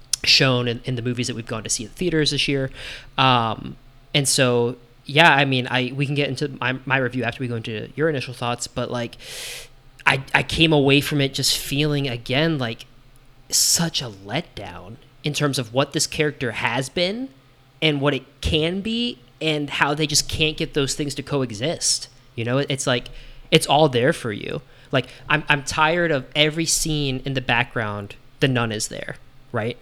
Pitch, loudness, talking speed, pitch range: 135 Hz, -21 LUFS, 195 wpm, 125-150 Hz